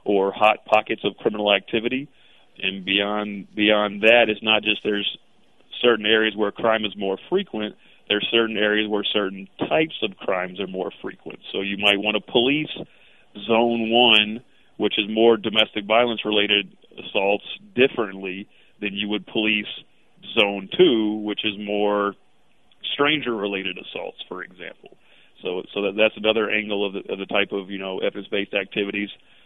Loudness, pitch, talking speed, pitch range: -21 LUFS, 105 Hz, 160 wpm, 100-110 Hz